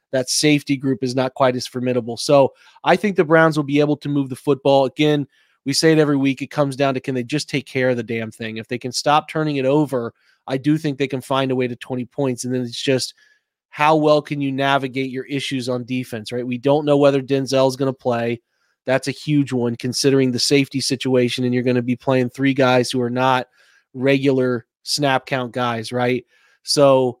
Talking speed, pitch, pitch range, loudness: 230 wpm, 135 Hz, 125-140 Hz, -19 LUFS